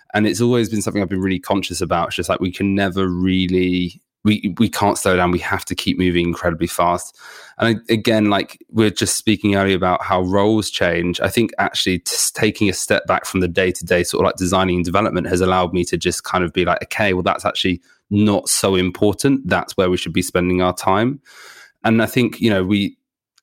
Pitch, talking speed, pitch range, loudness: 95 Hz, 230 wpm, 90-105 Hz, -18 LUFS